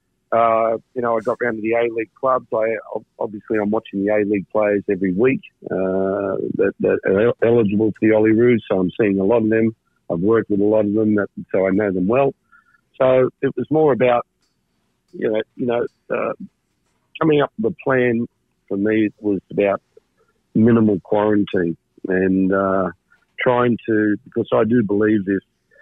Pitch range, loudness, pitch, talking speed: 100-120 Hz, -19 LUFS, 110 Hz, 190 wpm